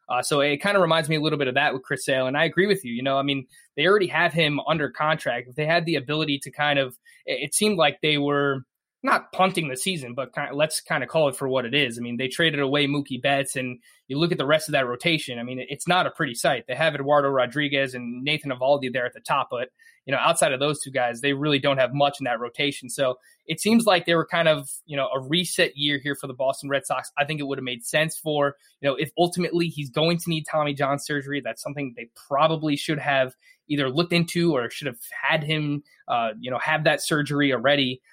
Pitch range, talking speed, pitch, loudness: 135-160 Hz, 270 wpm, 145 Hz, -24 LUFS